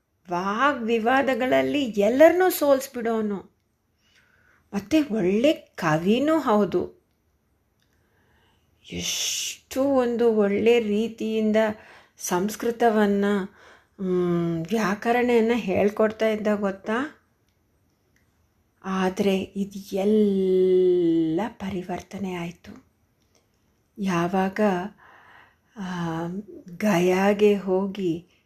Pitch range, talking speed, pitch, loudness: 180-230 Hz, 55 wpm, 200 Hz, -23 LUFS